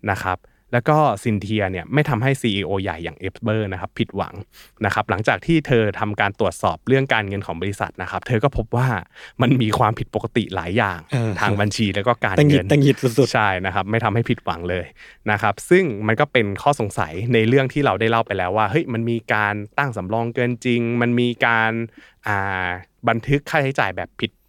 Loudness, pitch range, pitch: -20 LUFS, 100-125 Hz, 115 Hz